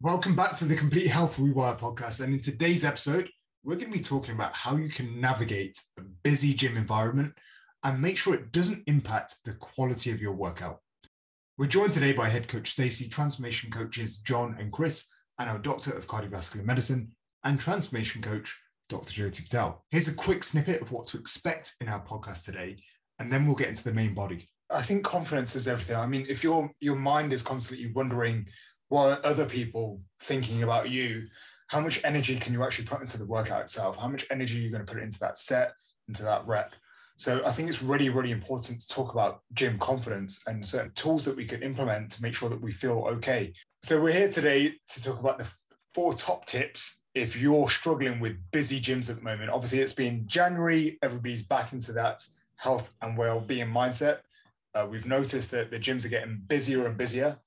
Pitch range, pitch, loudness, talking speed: 115-145 Hz, 130 Hz, -29 LUFS, 205 wpm